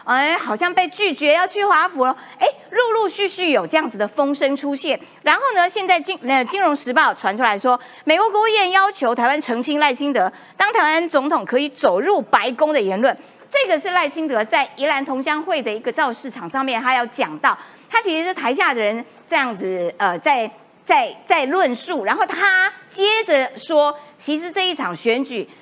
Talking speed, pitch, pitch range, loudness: 285 characters per minute, 295 Hz, 255-360 Hz, -18 LUFS